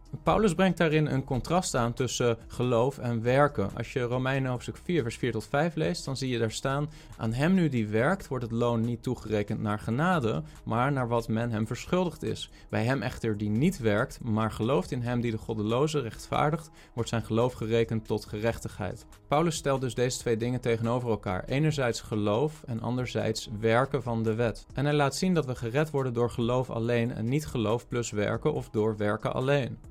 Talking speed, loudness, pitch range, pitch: 200 wpm, -29 LUFS, 115-145 Hz, 120 Hz